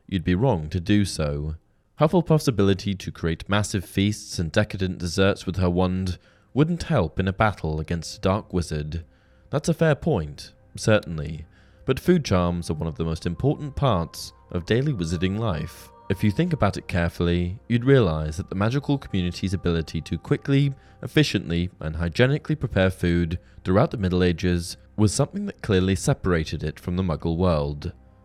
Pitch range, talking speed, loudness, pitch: 85-115 Hz, 170 wpm, -24 LUFS, 95 Hz